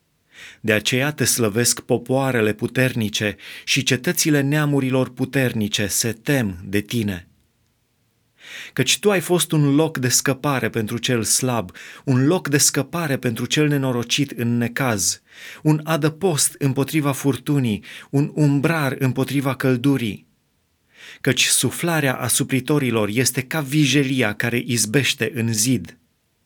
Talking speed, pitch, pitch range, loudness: 120 wpm, 130 Hz, 115-145 Hz, -20 LUFS